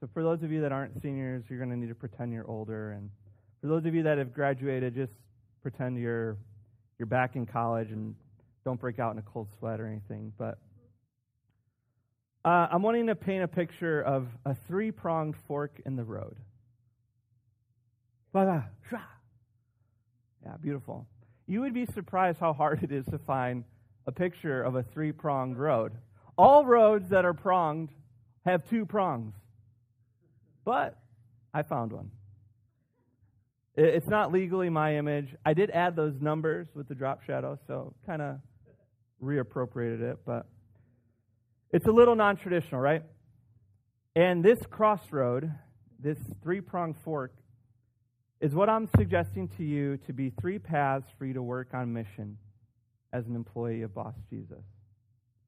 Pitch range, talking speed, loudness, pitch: 115-155 Hz, 155 wpm, -30 LUFS, 125 Hz